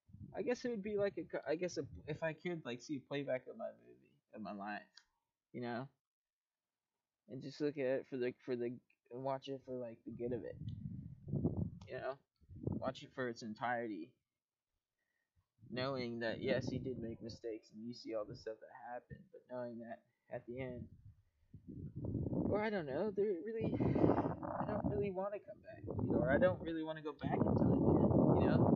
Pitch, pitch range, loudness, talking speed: 130 Hz, 120-150 Hz, -40 LUFS, 200 wpm